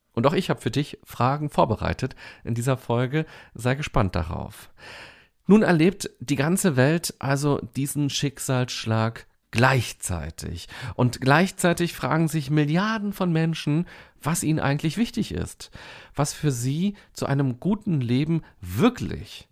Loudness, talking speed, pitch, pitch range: -24 LUFS, 130 wpm, 140 Hz, 125-165 Hz